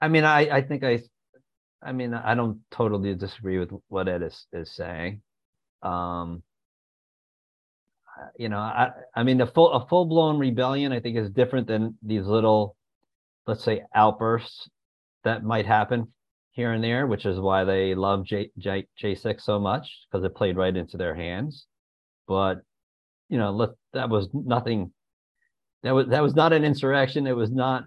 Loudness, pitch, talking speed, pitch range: -25 LUFS, 115 Hz, 175 wpm, 95-130 Hz